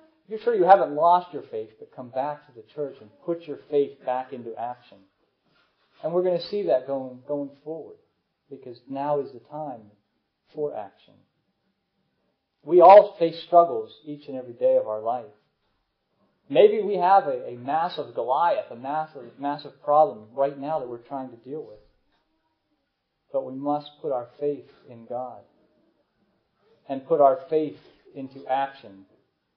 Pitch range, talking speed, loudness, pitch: 130-180 Hz, 160 wpm, -23 LUFS, 145 Hz